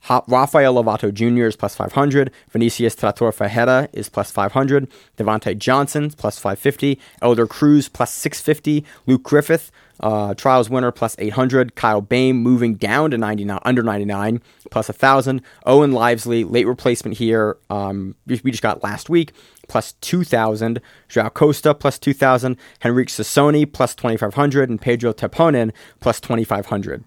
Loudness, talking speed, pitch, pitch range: -18 LUFS, 140 wpm, 120 Hz, 110-135 Hz